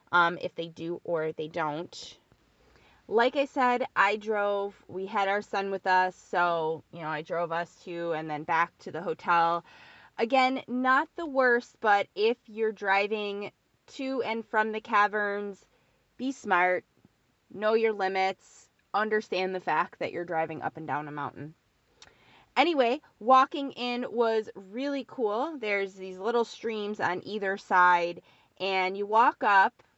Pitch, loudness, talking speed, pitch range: 205 Hz, -28 LUFS, 155 wpm, 175-230 Hz